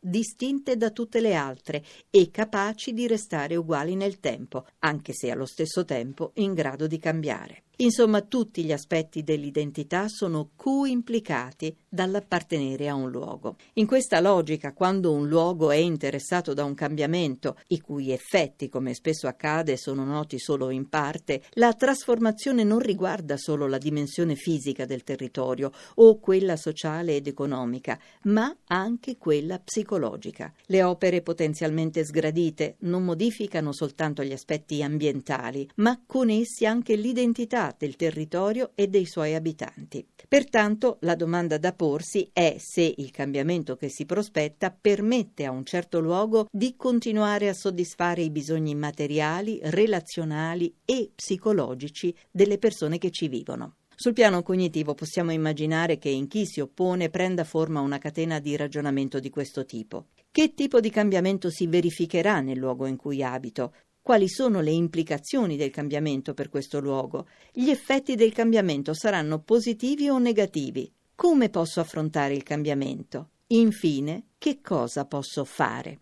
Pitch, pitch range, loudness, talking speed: 165 Hz, 150-210 Hz, -26 LUFS, 145 wpm